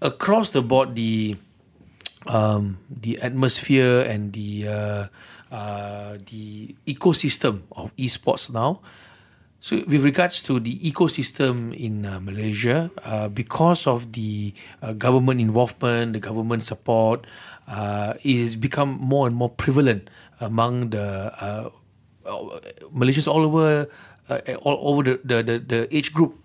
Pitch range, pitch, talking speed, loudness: 105-140 Hz, 120 Hz, 130 wpm, -22 LUFS